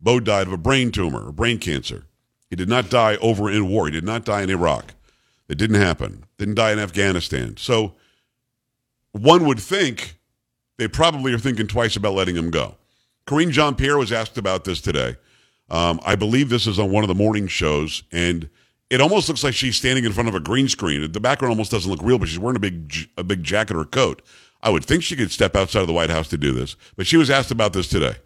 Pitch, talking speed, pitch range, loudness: 110 Hz, 240 wpm, 95-125 Hz, -20 LUFS